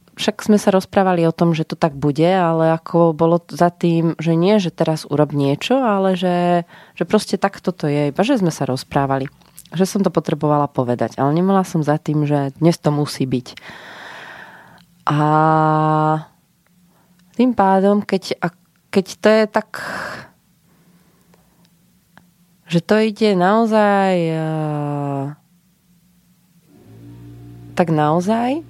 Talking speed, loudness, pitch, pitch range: 130 wpm, -17 LUFS, 170 Hz, 155-185 Hz